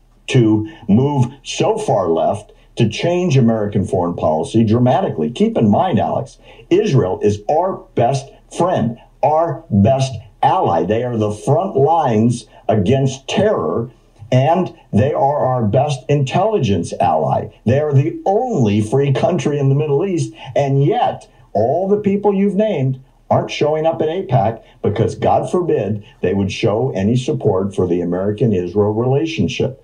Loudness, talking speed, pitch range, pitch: -16 LUFS, 145 wpm, 110-145 Hz, 125 Hz